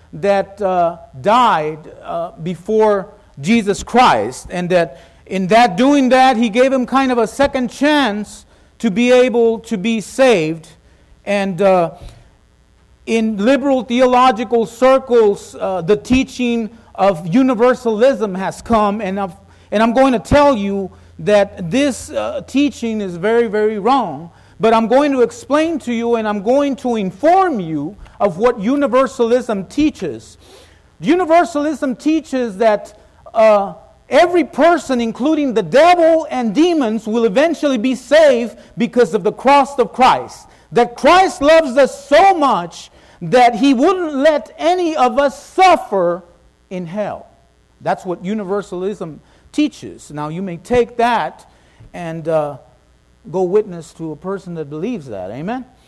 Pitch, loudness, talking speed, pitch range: 235 Hz, -15 LUFS, 140 wpm, 195-270 Hz